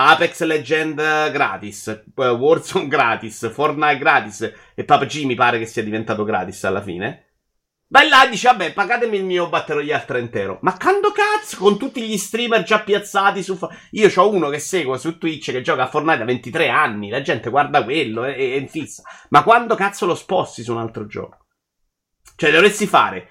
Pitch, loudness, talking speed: 155 Hz, -17 LUFS, 180 wpm